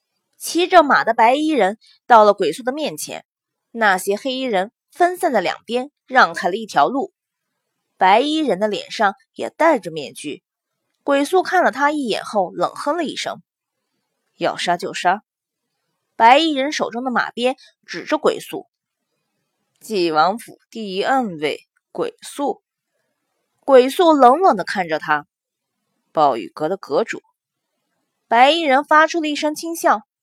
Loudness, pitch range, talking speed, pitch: -18 LUFS, 210-320 Hz, 205 characters per minute, 265 Hz